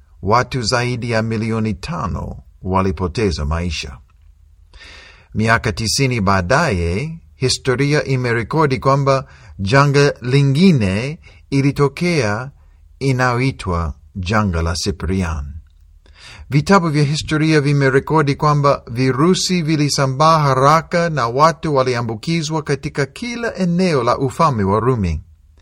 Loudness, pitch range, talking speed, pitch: -17 LUFS, 95-145 Hz, 85 wpm, 130 Hz